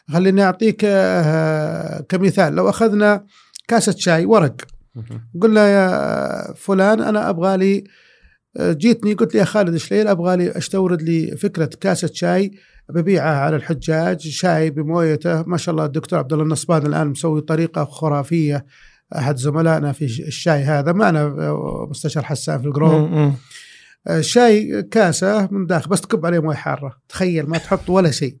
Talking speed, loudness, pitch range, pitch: 140 wpm, -17 LUFS, 155-195 Hz, 165 Hz